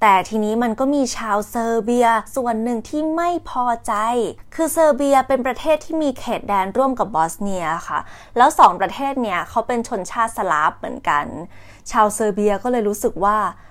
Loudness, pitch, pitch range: -19 LUFS, 230 Hz, 210-265 Hz